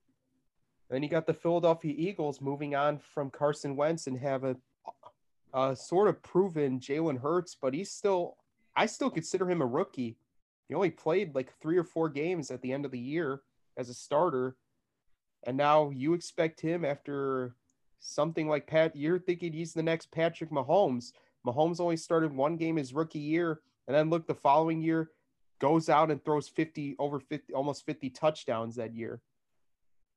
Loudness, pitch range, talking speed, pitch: -31 LUFS, 135-165 Hz, 175 wpm, 150 Hz